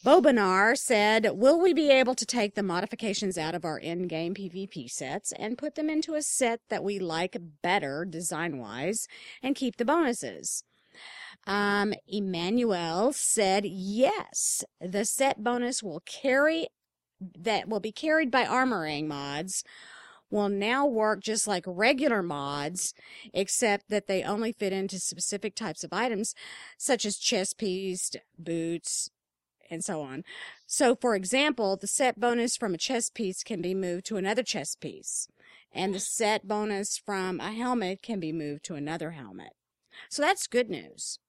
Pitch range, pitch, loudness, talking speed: 180-240 Hz, 205 Hz, -28 LUFS, 155 wpm